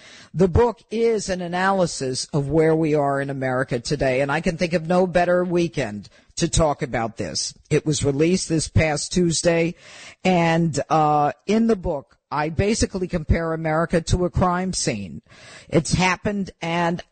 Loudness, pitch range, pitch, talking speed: -21 LUFS, 145-180 Hz, 165 Hz, 160 wpm